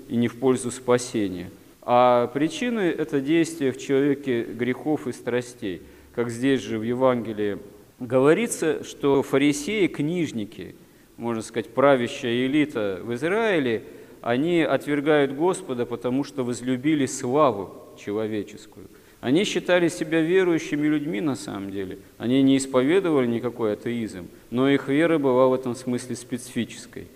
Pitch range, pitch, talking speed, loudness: 120-140 Hz, 125 Hz, 130 wpm, -24 LUFS